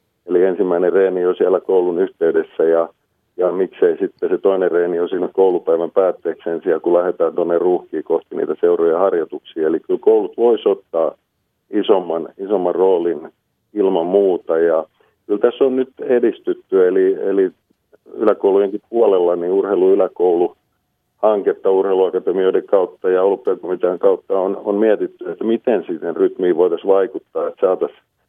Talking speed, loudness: 140 wpm, -17 LUFS